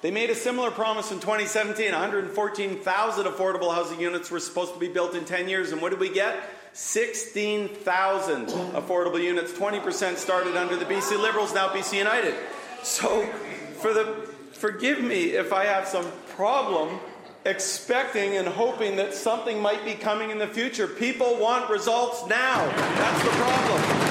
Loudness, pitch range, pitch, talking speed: -25 LUFS, 185-220 Hz, 205 Hz, 160 wpm